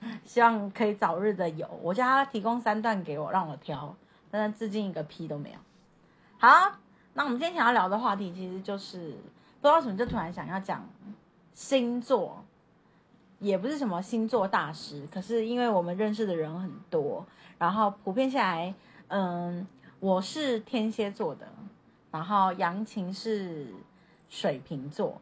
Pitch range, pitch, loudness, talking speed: 175-230 Hz, 200 Hz, -29 LUFS, 240 characters per minute